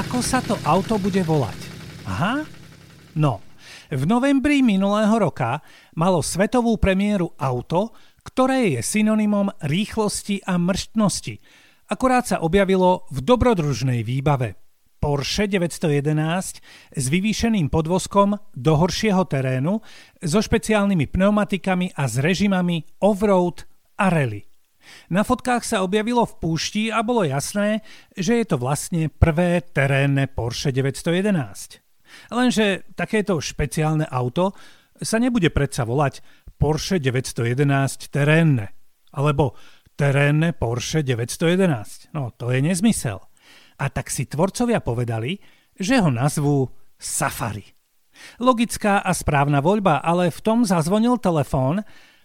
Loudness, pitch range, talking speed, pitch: -21 LUFS, 140-205 Hz, 115 wpm, 170 Hz